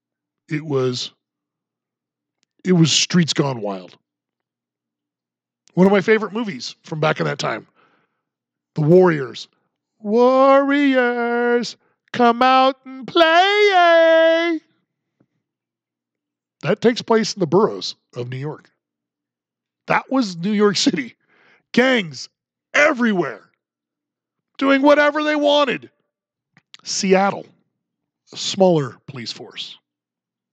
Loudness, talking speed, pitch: -17 LUFS, 95 wpm, 190 Hz